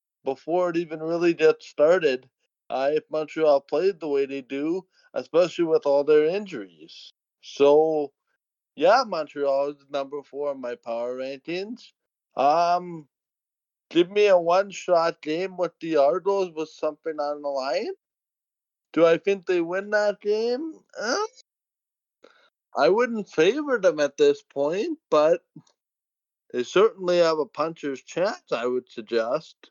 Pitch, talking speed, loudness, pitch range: 165 Hz, 135 wpm, -24 LUFS, 140-200 Hz